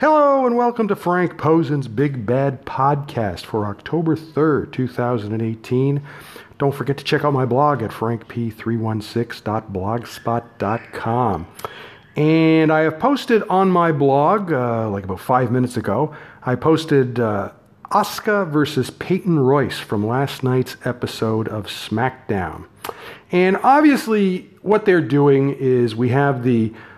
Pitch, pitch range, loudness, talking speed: 135 Hz, 115-160 Hz, -19 LUFS, 125 wpm